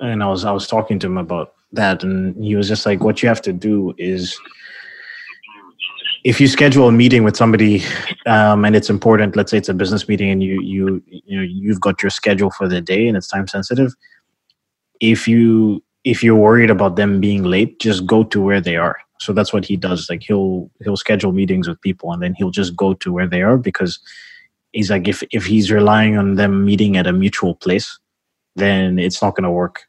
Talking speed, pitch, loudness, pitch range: 220 wpm, 100 Hz, -15 LUFS, 95-110 Hz